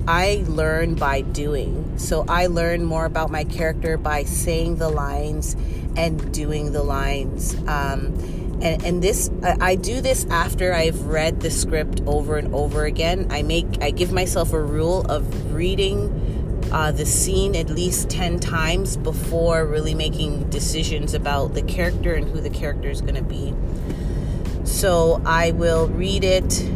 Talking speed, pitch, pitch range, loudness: 160 wpm, 160 Hz, 145-165 Hz, -22 LUFS